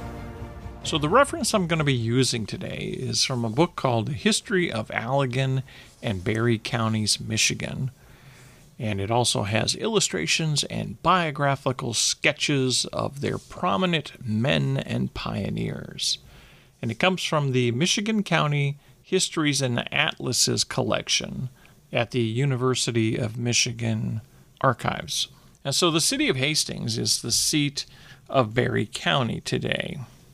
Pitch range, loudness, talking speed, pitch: 120-155 Hz, -24 LUFS, 130 wpm, 130 Hz